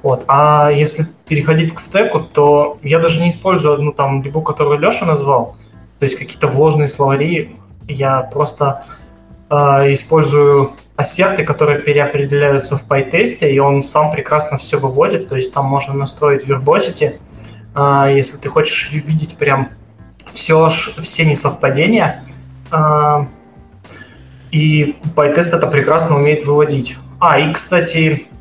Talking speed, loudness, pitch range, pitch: 130 wpm, -13 LUFS, 135-155 Hz, 145 Hz